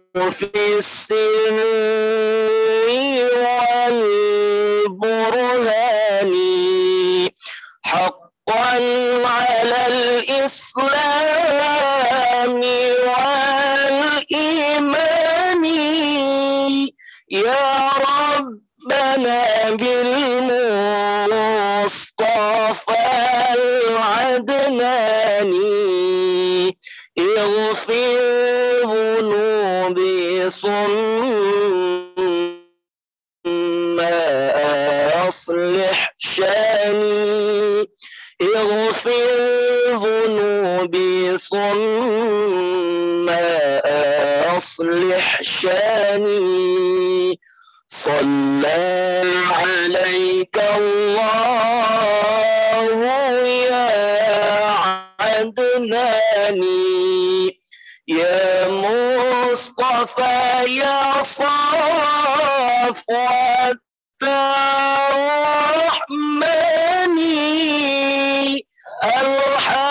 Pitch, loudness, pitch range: 245 Hz, -17 LUFS, 205-280 Hz